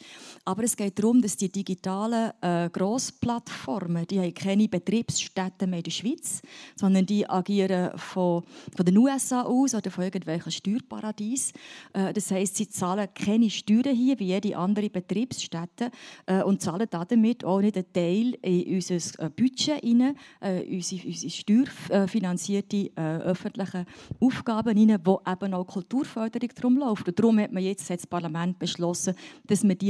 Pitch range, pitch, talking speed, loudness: 185-230 Hz, 195 Hz, 155 wpm, -27 LUFS